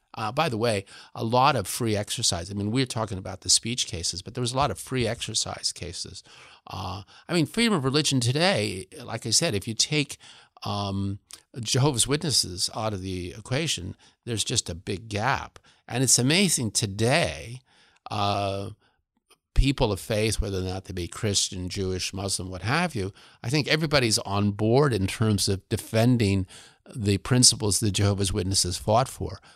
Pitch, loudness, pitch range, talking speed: 110 Hz, -25 LUFS, 100-125 Hz, 175 wpm